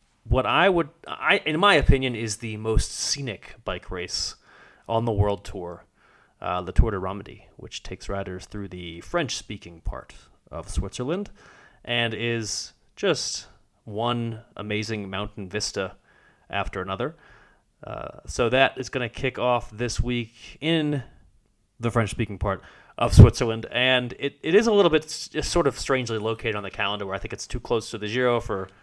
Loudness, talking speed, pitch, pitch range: -25 LUFS, 165 wpm, 115 Hz, 100-125 Hz